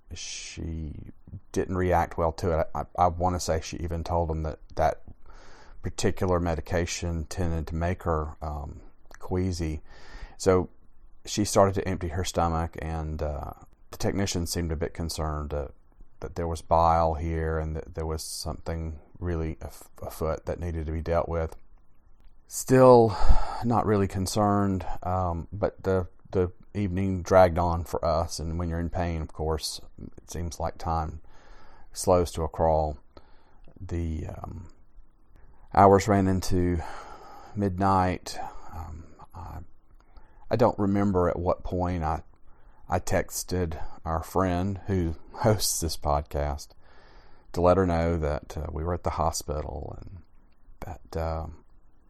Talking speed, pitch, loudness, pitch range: 145 wpm, 85 Hz, -27 LUFS, 80-95 Hz